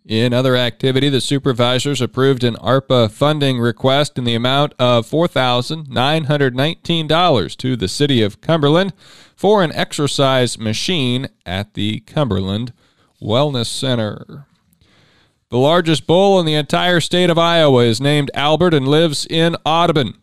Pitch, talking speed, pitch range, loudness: 135 Hz, 135 wpm, 120-155 Hz, -16 LUFS